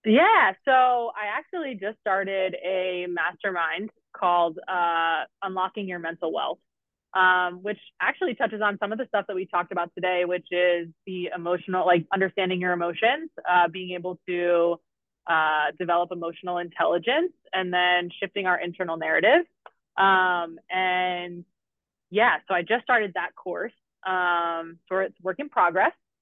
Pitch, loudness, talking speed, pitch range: 180 Hz, -25 LUFS, 150 wpm, 175-195 Hz